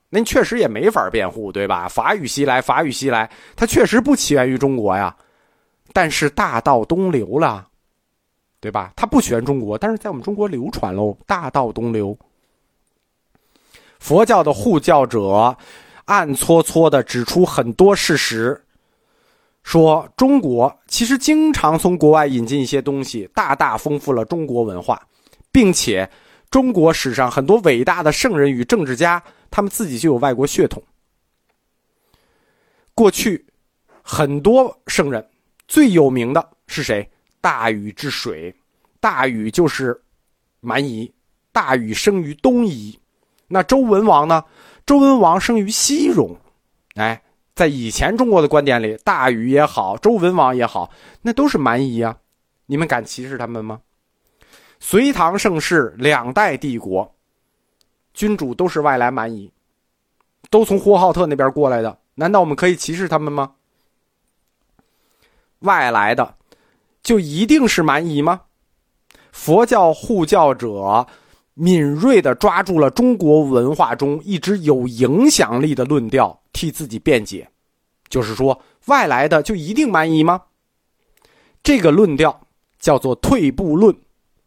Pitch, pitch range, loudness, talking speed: 150 Hz, 130-200 Hz, -16 LUFS, 210 characters per minute